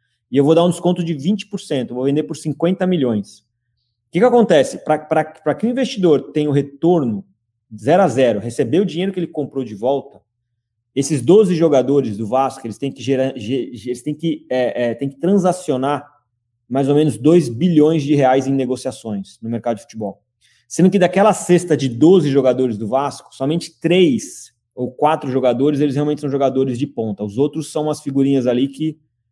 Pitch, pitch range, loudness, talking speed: 140 Hz, 125-160 Hz, -17 LUFS, 190 wpm